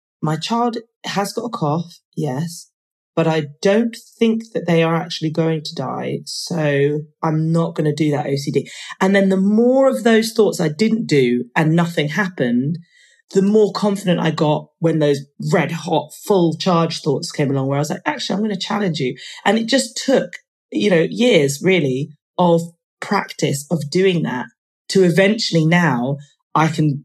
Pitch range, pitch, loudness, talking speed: 150-200 Hz, 165 Hz, -18 LUFS, 180 wpm